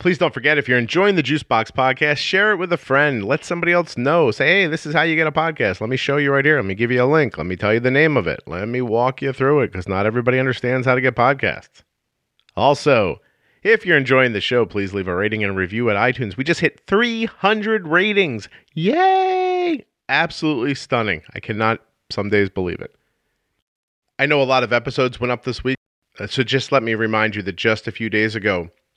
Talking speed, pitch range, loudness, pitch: 235 wpm, 110-160 Hz, -18 LUFS, 130 Hz